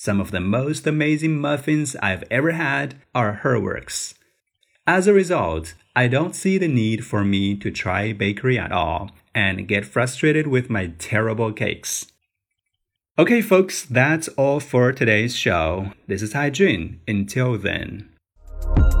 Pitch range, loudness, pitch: 100-145 Hz, -21 LUFS, 110 Hz